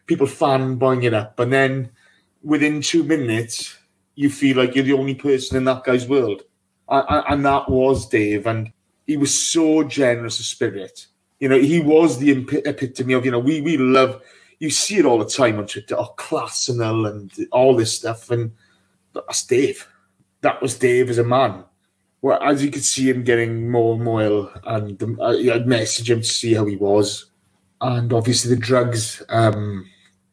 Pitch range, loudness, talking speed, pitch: 115-140 Hz, -19 LUFS, 190 wpm, 125 Hz